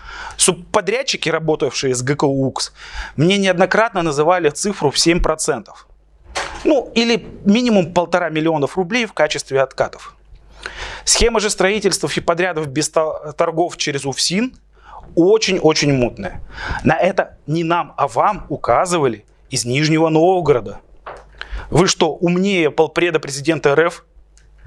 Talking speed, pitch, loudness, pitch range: 115 wpm, 165 Hz, -17 LUFS, 150-190 Hz